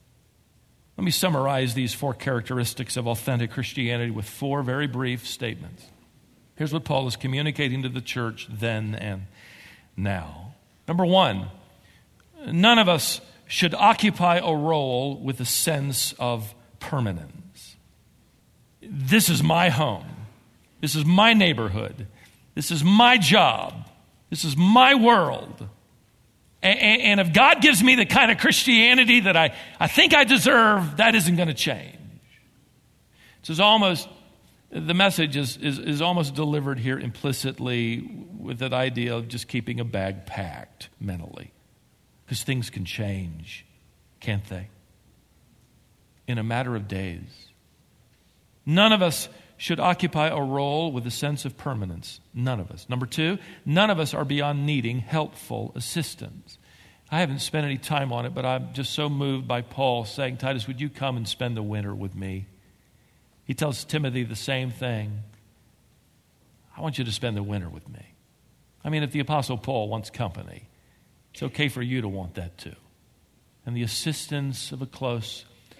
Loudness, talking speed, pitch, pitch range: -22 LUFS, 155 wpm, 130 Hz, 115-155 Hz